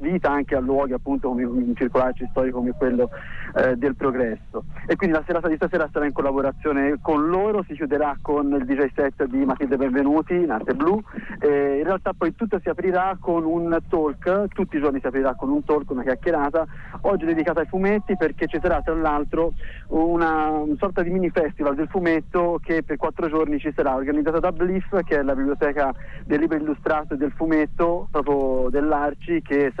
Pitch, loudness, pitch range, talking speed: 150 Hz, -23 LUFS, 140-170 Hz, 195 wpm